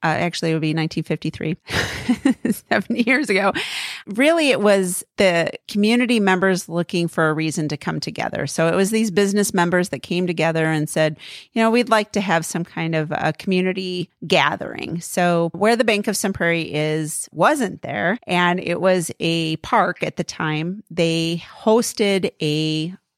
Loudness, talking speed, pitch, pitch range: -20 LUFS, 170 wpm, 175 Hz, 160-205 Hz